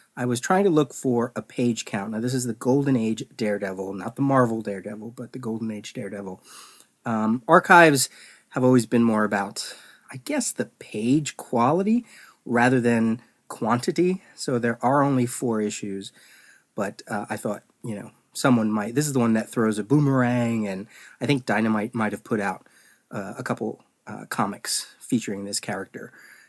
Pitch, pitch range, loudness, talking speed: 120 Hz, 110-130 Hz, -24 LUFS, 175 wpm